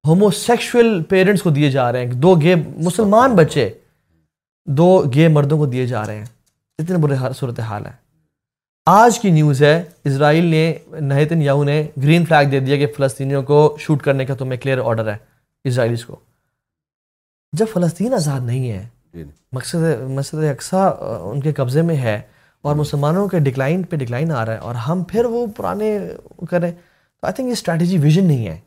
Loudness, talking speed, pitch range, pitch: -17 LUFS, 180 wpm, 130-170 Hz, 150 Hz